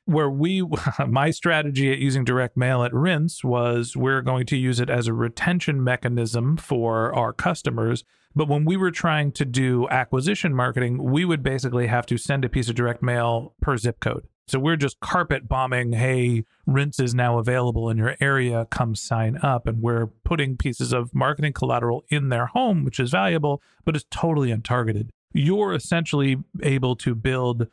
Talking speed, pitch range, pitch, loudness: 180 wpm, 120-150 Hz, 130 Hz, -23 LUFS